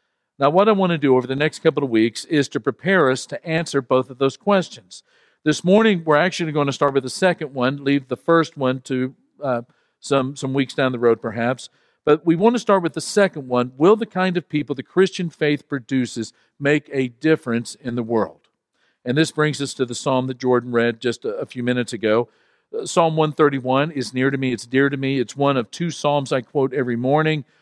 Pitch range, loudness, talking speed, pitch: 130-160 Hz, -20 LUFS, 230 wpm, 140 Hz